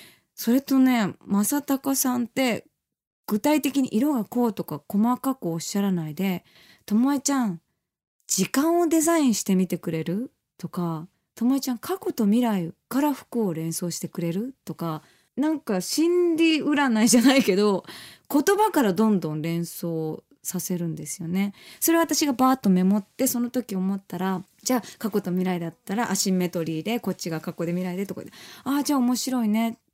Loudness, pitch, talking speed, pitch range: -24 LUFS, 210 Hz, 345 characters per minute, 180-265 Hz